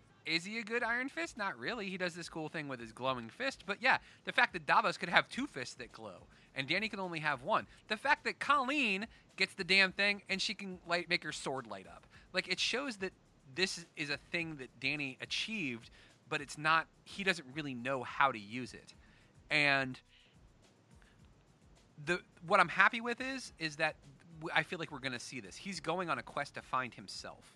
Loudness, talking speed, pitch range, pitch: -35 LUFS, 215 wpm, 135-195 Hz, 170 Hz